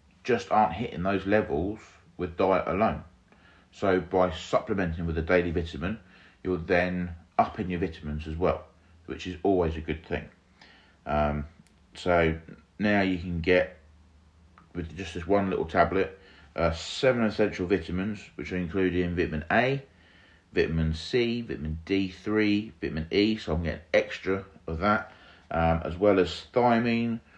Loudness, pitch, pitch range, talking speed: -28 LUFS, 90 Hz, 80-100 Hz, 145 wpm